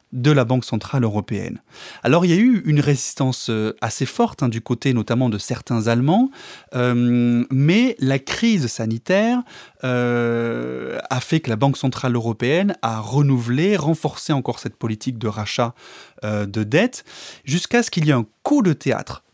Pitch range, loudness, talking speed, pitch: 115-155 Hz, -20 LUFS, 170 wpm, 125 Hz